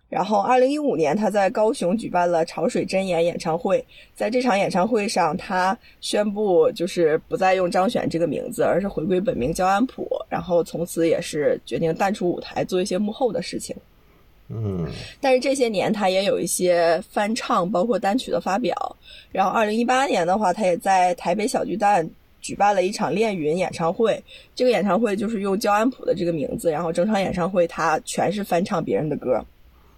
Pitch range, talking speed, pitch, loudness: 170-235 Hz, 300 characters per minute, 190 Hz, -22 LUFS